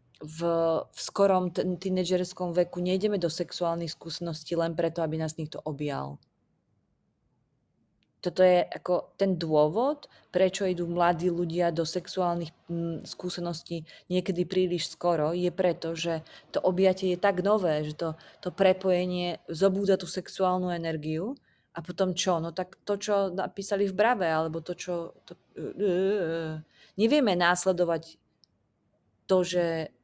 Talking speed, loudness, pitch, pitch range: 140 wpm, -28 LUFS, 180 Hz, 165-185 Hz